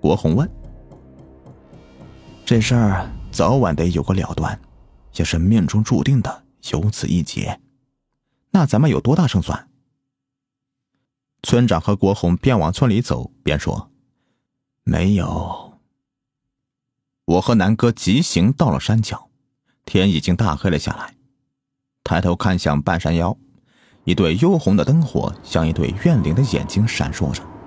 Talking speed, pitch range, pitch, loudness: 195 characters per minute, 85-135 Hz, 105 Hz, -18 LUFS